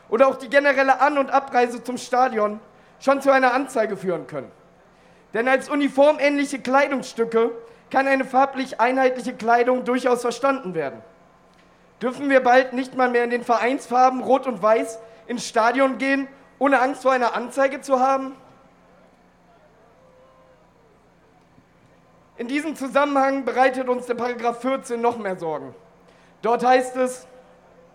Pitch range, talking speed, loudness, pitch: 235-270 Hz, 135 wpm, -21 LUFS, 255 Hz